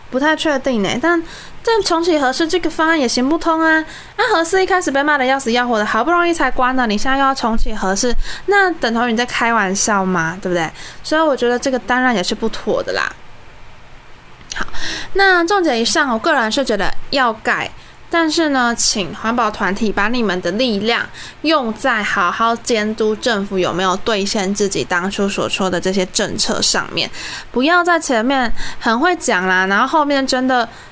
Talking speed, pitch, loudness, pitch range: 285 characters per minute, 245 Hz, -16 LUFS, 210-310 Hz